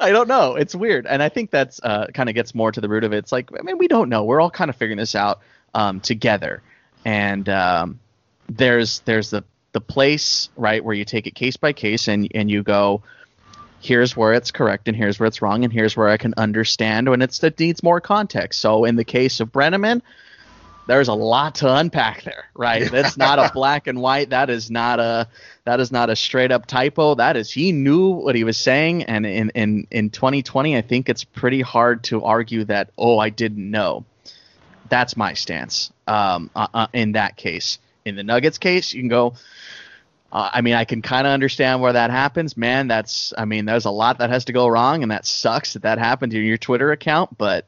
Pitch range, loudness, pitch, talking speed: 110-135 Hz, -19 LUFS, 120 Hz, 225 wpm